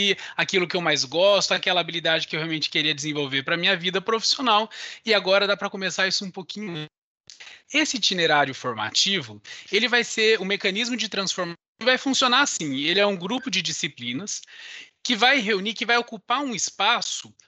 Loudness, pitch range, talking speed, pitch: -22 LUFS, 170-230 Hz, 180 wpm, 195 Hz